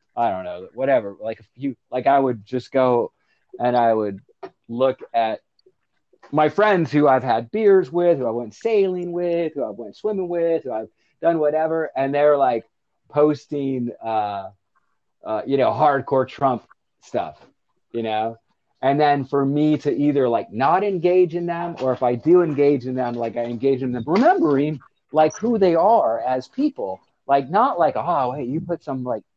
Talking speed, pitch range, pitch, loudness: 185 wpm, 125-170 Hz, 140 Hz, -21 LUFS